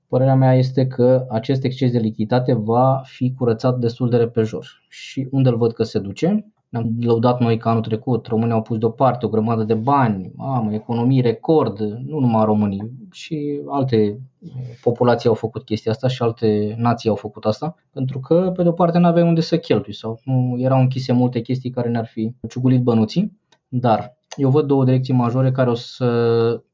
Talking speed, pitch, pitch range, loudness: 190 wpm, 125 Hz, 115-130 Hz, -19 LUFS